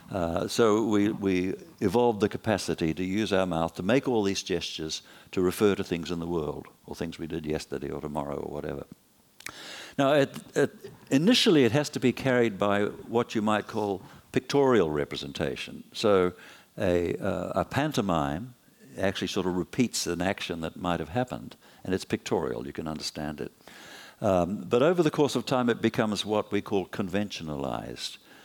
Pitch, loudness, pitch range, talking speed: 100 Hz, -28 LUFS, 85-115 Hz, 175 wpm